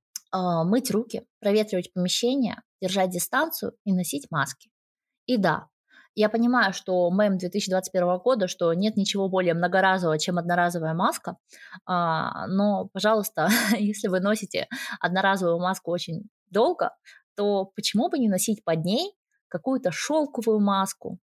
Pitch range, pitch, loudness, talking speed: 180-225 Hz, 195 Hz, -25 LUFS, 125 wpm